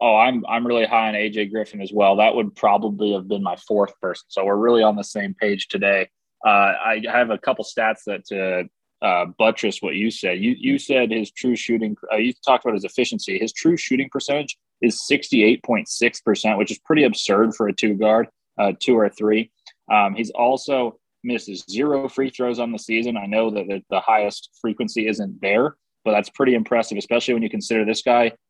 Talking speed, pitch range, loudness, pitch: 210 wpm, 105-120 Hz, -20 LUFS, 110 Hz